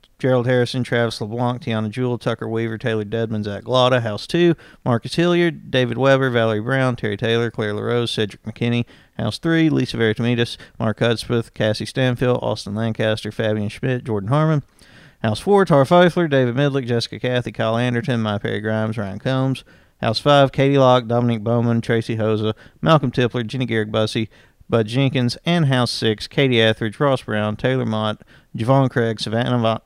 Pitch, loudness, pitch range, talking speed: 120 Hz, -19 LUFS, 110-130 Hz, 165 wpm